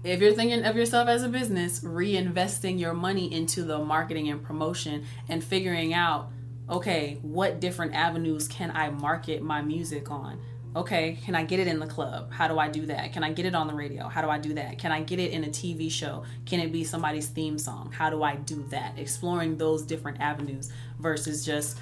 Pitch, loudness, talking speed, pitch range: 155 Hz, -29 LUFS, 215 wpm, 145-170 Hz